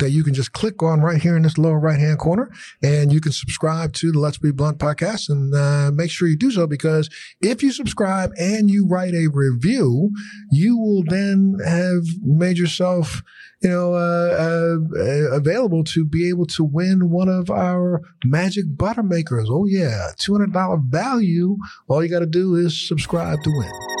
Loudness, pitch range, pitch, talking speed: -19 LUFS, 150-185 Hz, 170 Hz, 195 wpm